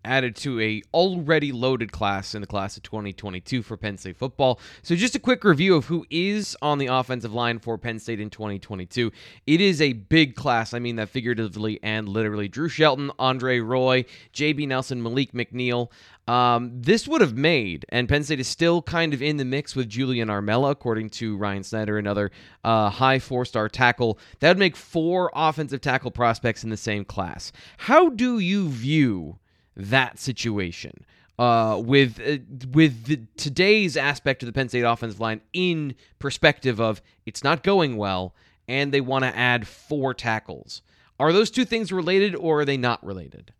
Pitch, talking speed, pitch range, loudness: 125 Hz, 185 wpm, 110-150 Hz, -23 LUFS